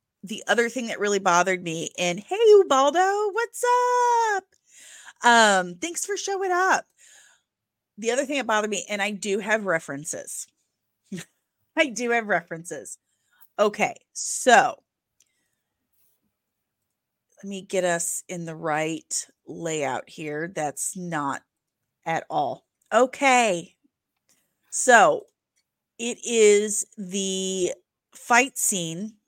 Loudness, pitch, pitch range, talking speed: -23 LUFS, 210 Hz, 180-275 Hz, 110 wpm